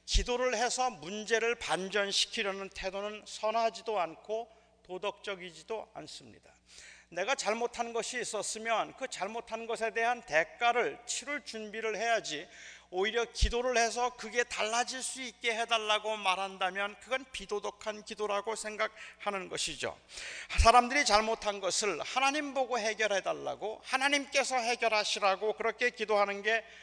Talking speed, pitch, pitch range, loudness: 320 characters per minute, 220 Hz, 205-240 Hz, -32 LUFS